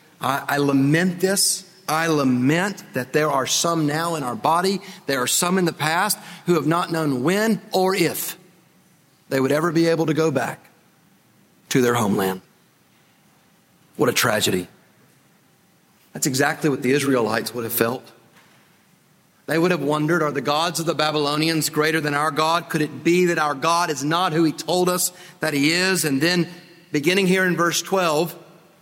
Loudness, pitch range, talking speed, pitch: -21 LUFS, 145-180 Hz, 175 wpm, 160 Hz